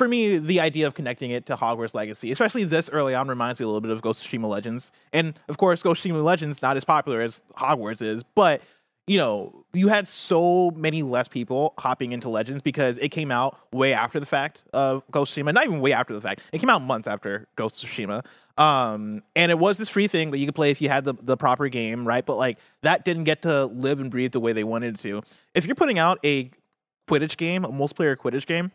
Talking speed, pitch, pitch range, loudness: 250 wpm, 140 Hz, 120-160 Hz, -24 LUFS